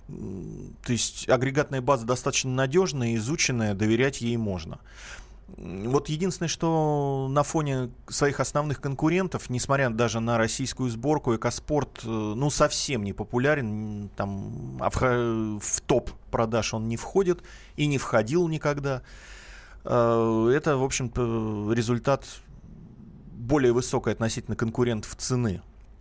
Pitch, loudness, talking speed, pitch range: 125 Hz, -26 LUFS, 110 wpm, 115-140 Hz